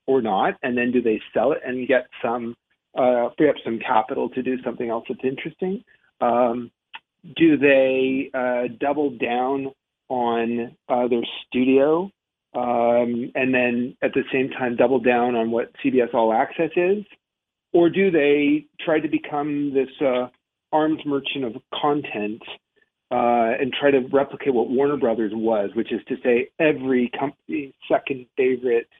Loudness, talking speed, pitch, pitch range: -22 LUFS, 155 wpm, 130 Hz, 120-145 Hz